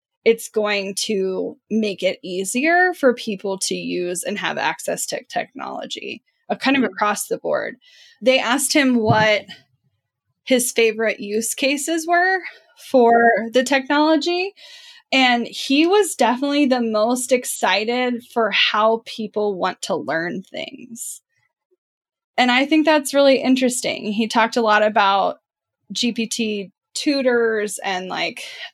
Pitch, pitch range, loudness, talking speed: 240 Hz, 210-285 Hz, -19 LUFS, 130 wpm